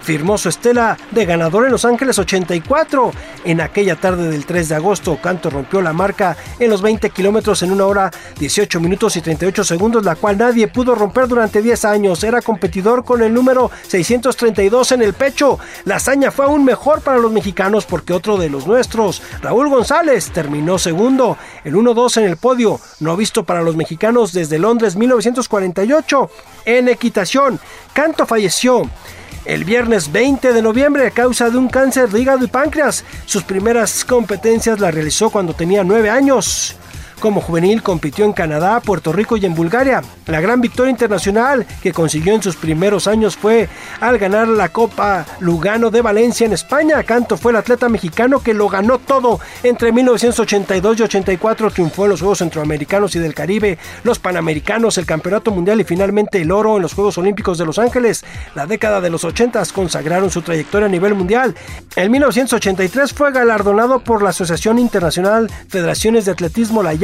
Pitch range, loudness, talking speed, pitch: 185-235 Hz, -14 LUFS, 175 wpm, 210 Hz